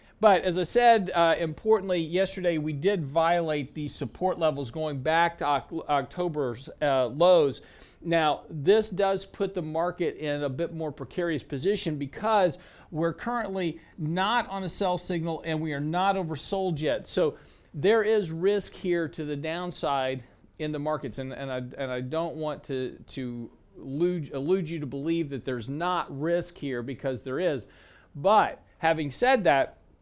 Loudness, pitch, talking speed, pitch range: -27 LUFS, 165 Hz, 160 wpm, 145-185 Hz